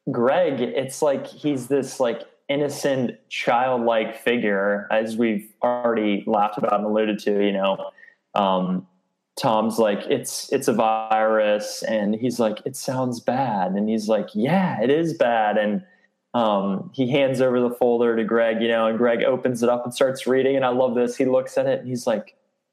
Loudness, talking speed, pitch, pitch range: -22 LUFS, 180 wpm, 115 Hz, 105-130 Hz